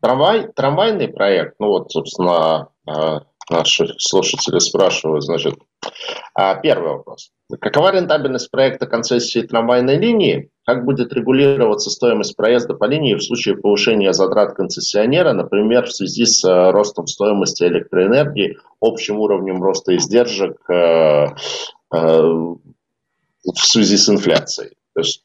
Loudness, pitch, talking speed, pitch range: -15 LUFS, 120 Hz, 110 wpm, 100-140 Hz